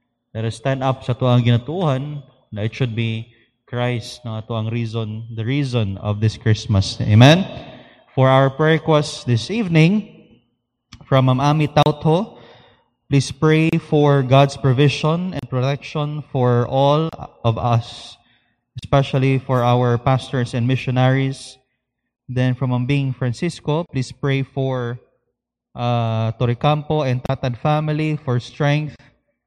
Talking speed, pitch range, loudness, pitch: 120 wpm, 120-145 Hz, -19 LUFS, 130 Hz